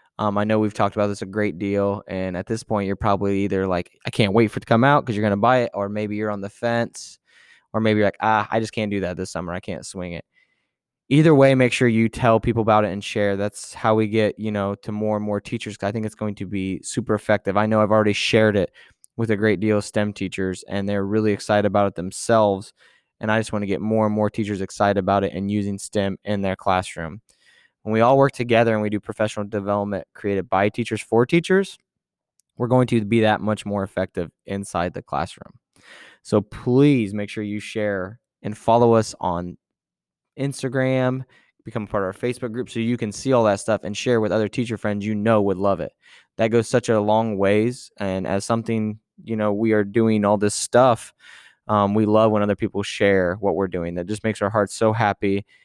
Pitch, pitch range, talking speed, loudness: 105 Hz, 100-115 Hz, 235 wpm, -21 LUFS